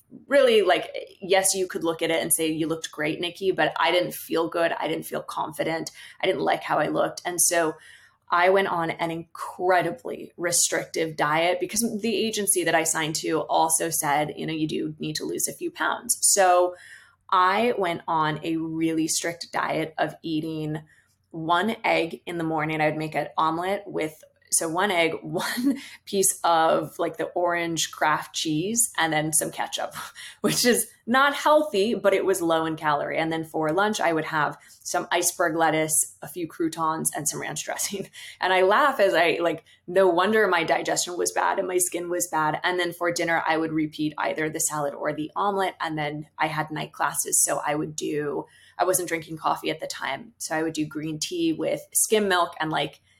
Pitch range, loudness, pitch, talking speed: 160-190 Hz, -24 LUFS, 170 Hz, 200 wpm